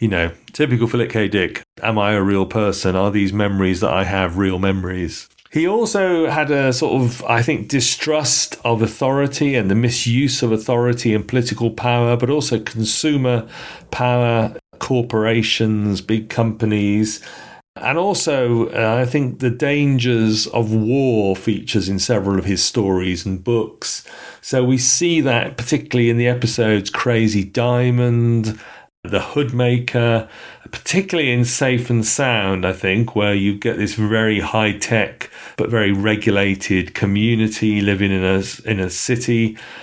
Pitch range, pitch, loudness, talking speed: 105-125 Hz, 115 Hz, -18 LUFS, 150 wpm